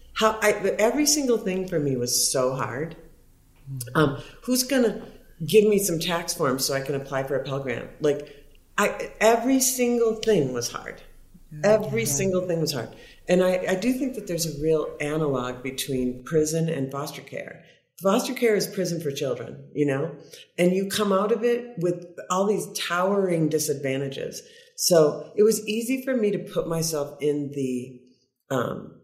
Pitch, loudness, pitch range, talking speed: 165 Hz, -24 LUFS, 140-210 Hz, 175 wpm